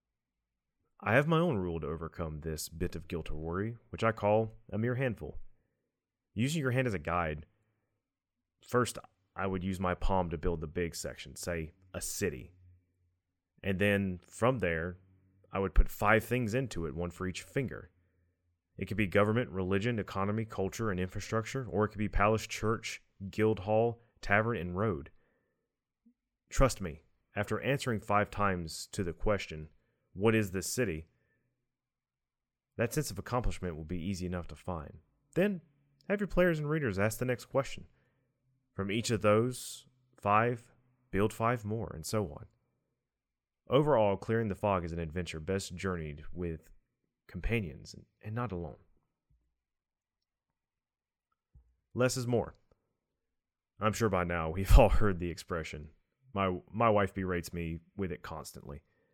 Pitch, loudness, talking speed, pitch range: 100 Hz, -33 LUFS, 155 wpm, 90-115 Hz